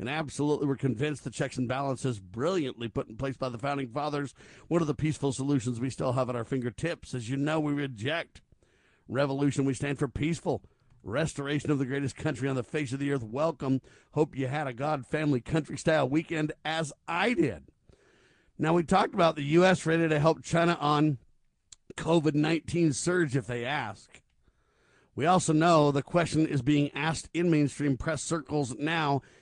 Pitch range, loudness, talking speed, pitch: 135-155 Hz, -29 LUFS, 185 wpm, 145 Hz